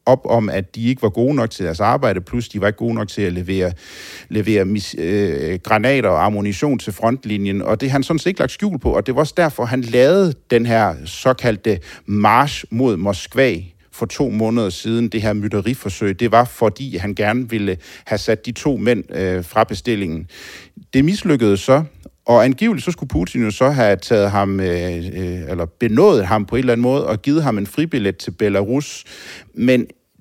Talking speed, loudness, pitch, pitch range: 205 wpm, -18 LUFS, 110 Hz, 100-130 Hz